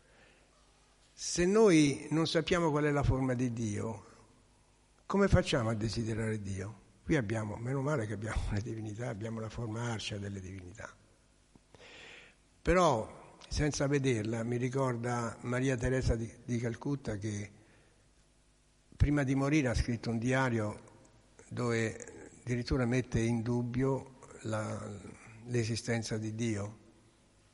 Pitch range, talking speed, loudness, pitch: 110-130 Hz, 120 wpm, -33 LUFS, 115 Hz